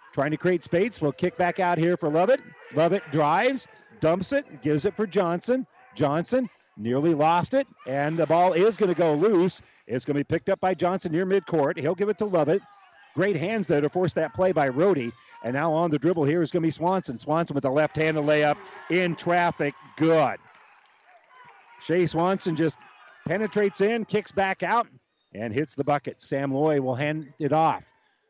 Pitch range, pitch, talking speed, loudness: 150-195 Hz, 170 Hz, 195 wpm, -25 LUFS